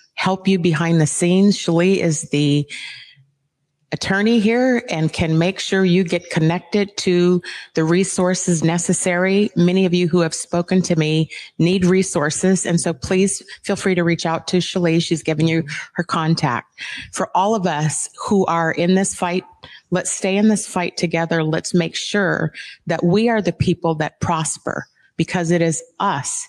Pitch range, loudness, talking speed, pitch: 165-190 Hz, -18 LUFS, 170 wpm, 175 Hz